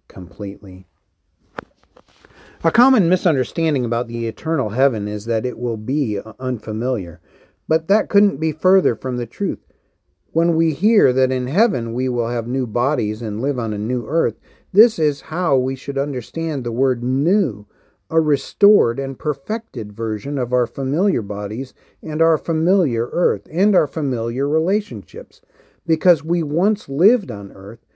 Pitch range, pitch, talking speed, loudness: 115-165 Hz, 135 Hz, 150 wpm, -19 LUFS